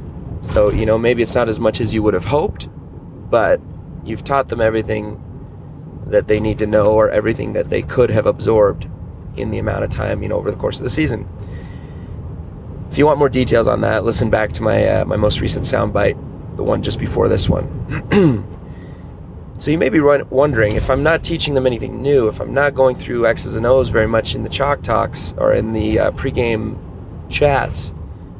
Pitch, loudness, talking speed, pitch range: 115 Hz, -16 LUFS, 205 wpm, 105-135 Hz